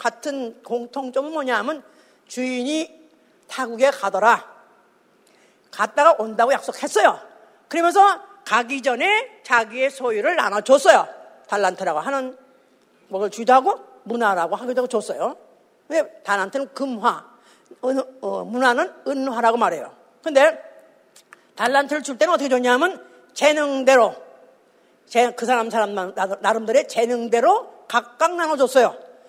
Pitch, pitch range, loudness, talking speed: 255 Hz, 230-295 Hz, -20 LUFS, 275 characters per minute